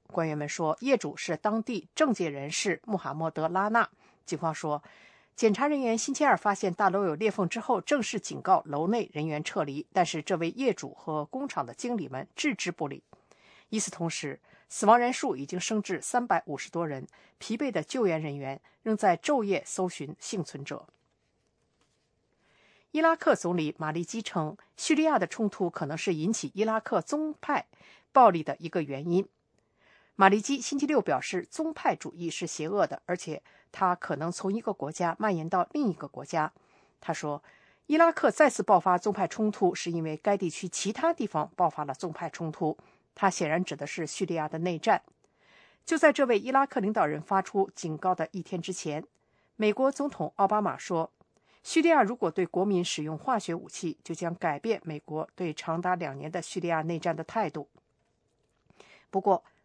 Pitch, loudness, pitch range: 185 Hz, -29 LUFS, 160-220 Hz